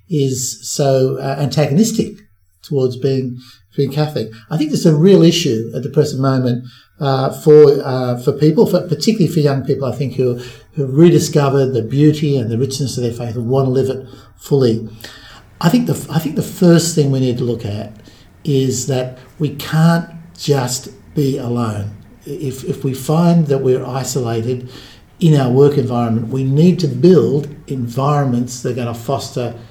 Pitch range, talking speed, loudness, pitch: 125-150 Hz, 180 wpm, -15 LUFS, 135 Hz